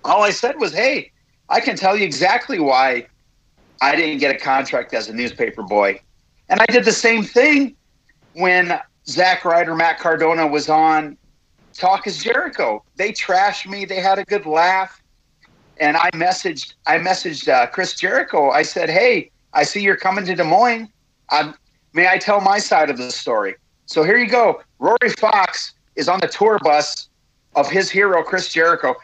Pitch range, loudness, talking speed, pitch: 155-215 Hz, -17 LUFS, 180 wpm, 190 Hz